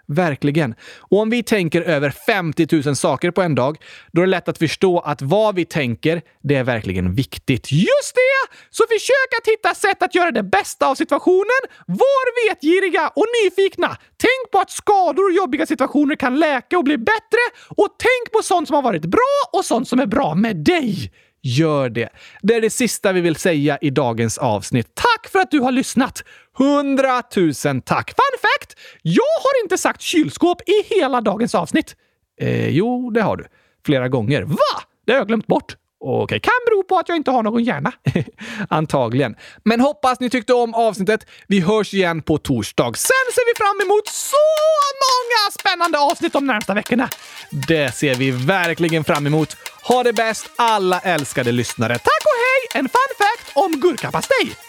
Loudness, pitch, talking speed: -18 LUFS, 250 Hz, 185 wpm